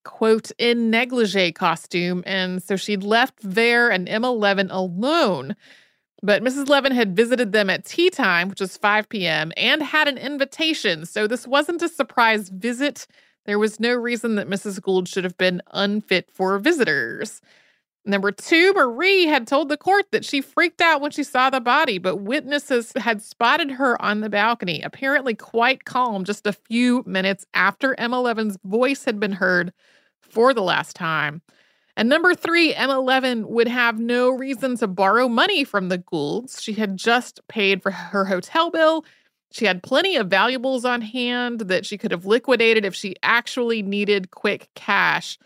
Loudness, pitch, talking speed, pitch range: -20 LUFS, 230 Hz, 170 wpm, 200-265 Hz